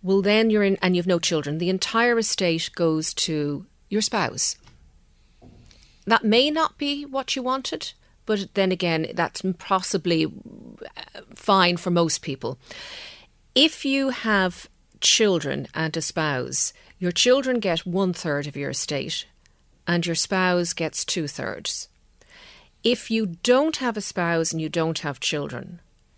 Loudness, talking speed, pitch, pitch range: -23 LUFS, 145 wpm, 185 Hz, 165-225 Hz